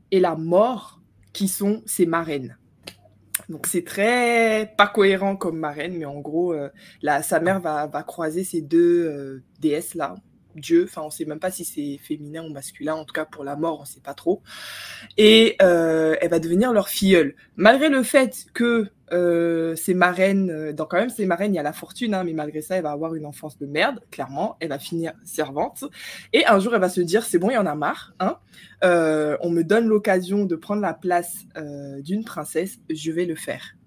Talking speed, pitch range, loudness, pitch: 215 wpm, 155-195 Hz, -22 LUFS, 170 Hz